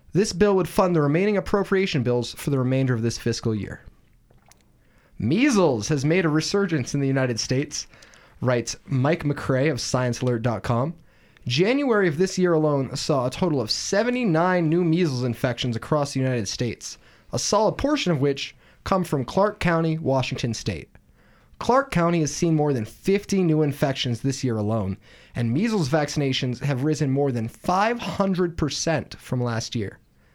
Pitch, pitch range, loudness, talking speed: 145 Hz, 125-175 Hz, -23 LUFS, 160 wpm